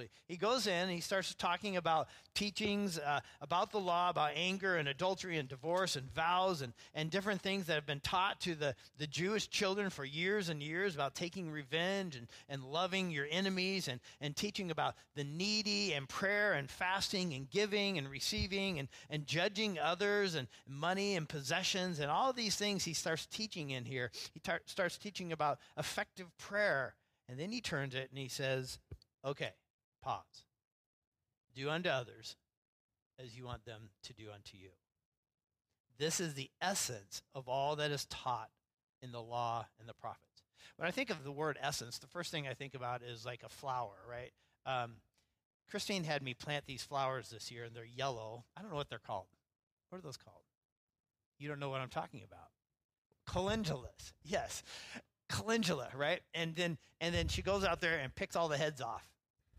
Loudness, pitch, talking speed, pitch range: -38 LUFS, 150 Hz, 185 wpm, 125-185 Hz